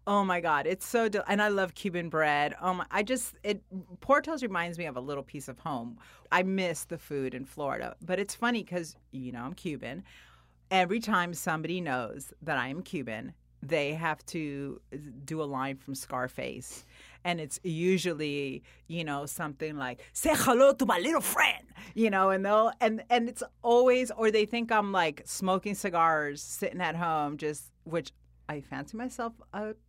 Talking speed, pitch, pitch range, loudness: 185 wpm, 175 Hz, 145-210 Hz, -30 LUFS